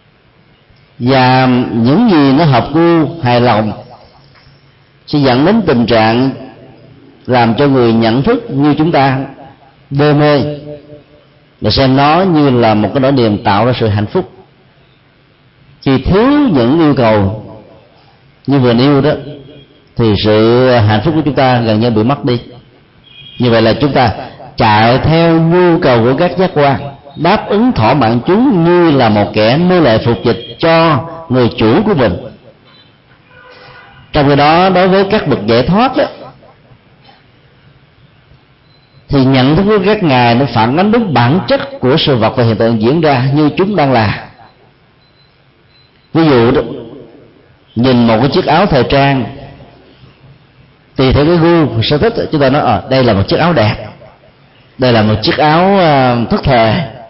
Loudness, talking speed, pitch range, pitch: -10 LUFS, 165 wpm, 120-150 Hz, 135 Hz